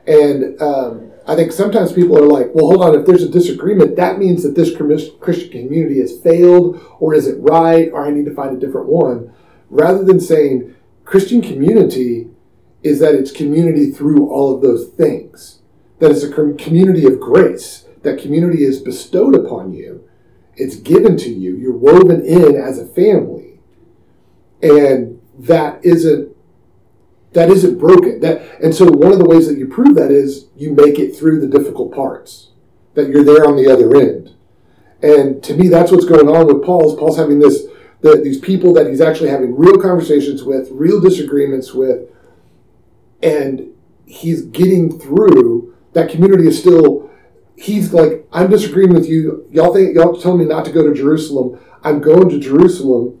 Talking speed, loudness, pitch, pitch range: 175 wpm, -11 LUFS, 155 Hz, 145-180 Hz